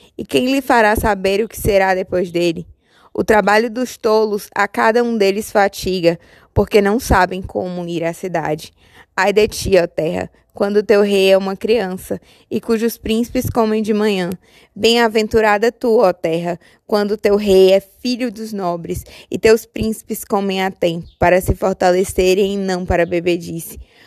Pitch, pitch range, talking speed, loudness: 200 Hz, 185-220 Hz, 165 wpm, -16 LUFS